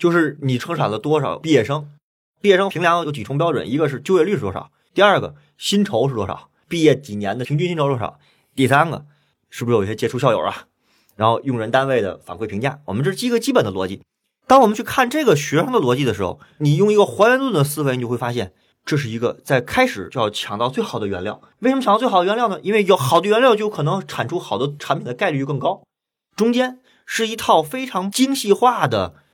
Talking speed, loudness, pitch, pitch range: 355 characters per minute, -19 LUFS, 155 Hz, 135-205 Hz